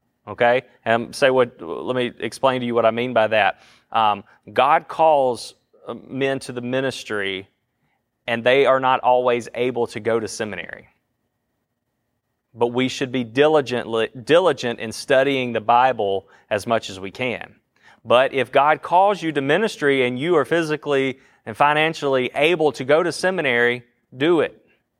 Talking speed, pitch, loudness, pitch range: 160 wpm, 125 Hz, -20 LUFS, 120-135 Hz